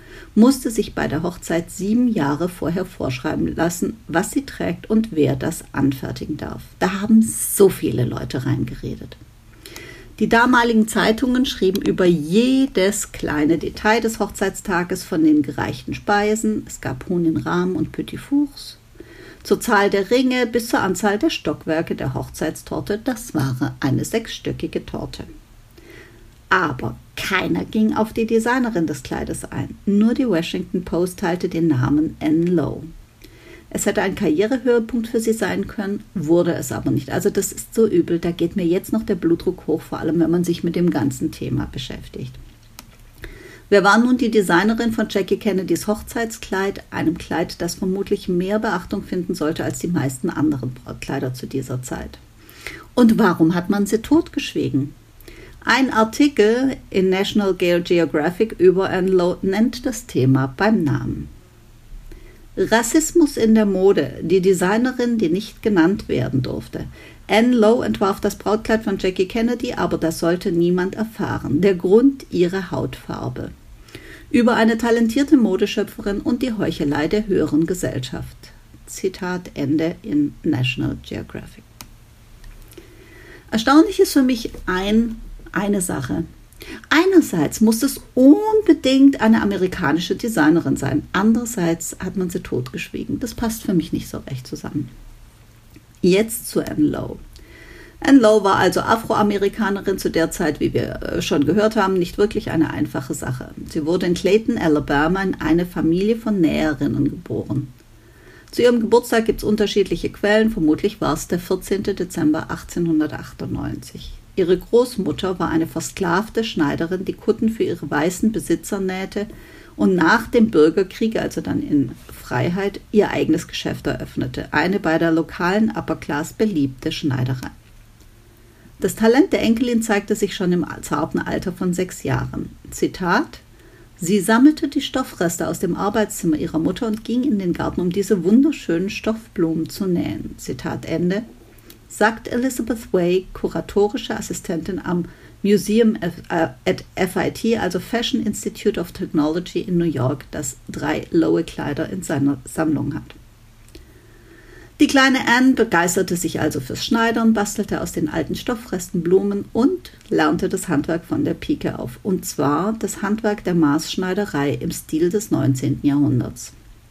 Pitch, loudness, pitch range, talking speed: 185 Hz, -19 LUFS, 160-220 Hz, 145 wpm